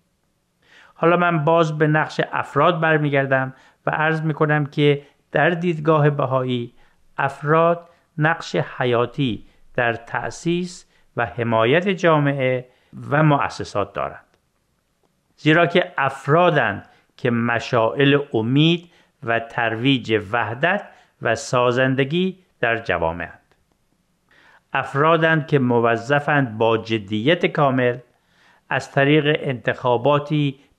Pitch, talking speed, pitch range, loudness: 140 Hz, 95 wpm, 120-160 Hz, -20 LUFS